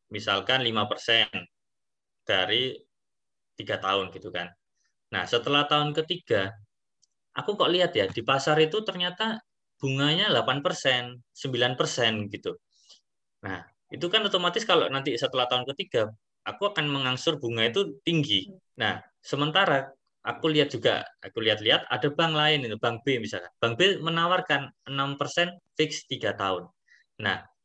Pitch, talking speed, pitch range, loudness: 145 Hz, 130 wpm, 120-170 Hz, -26 LUFS